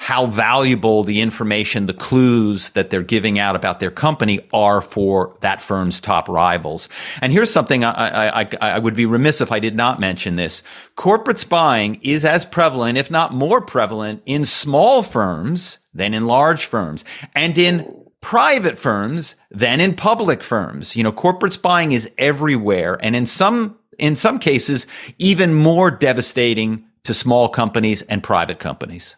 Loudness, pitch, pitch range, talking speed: -17 LUFS, 120 Hz, 110-160 Hz, 165 wpm